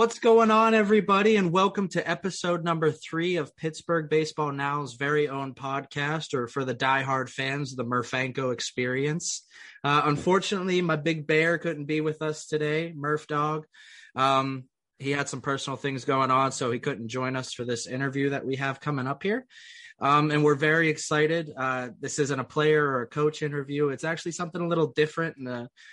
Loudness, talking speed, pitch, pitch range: -26 LUFS, 185 wpm, 150 Hz, 135-165 Hz